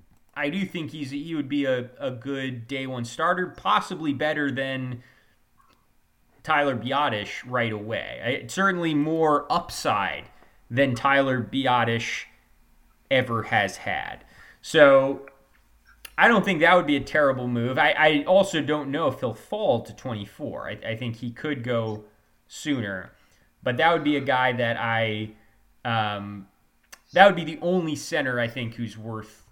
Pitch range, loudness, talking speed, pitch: 115-150 Hz, -24 LUFS, 155 wpm, 130 Hz